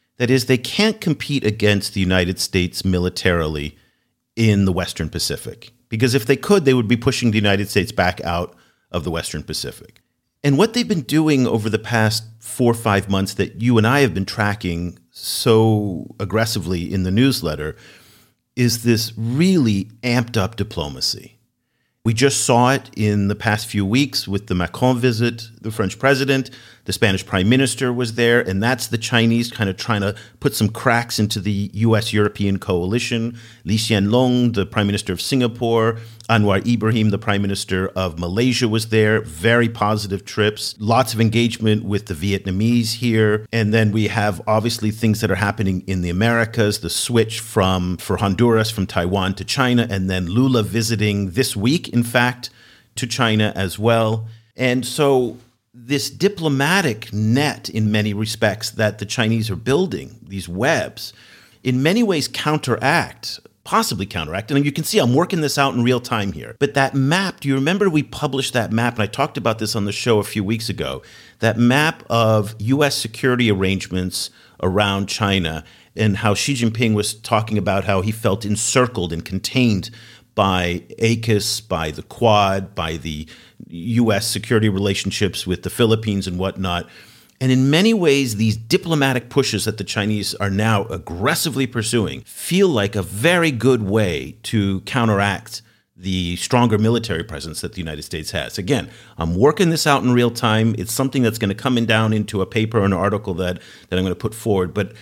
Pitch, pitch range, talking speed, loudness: 110 Hz, 100-120 Hz, 175 wpm, -19 LUFS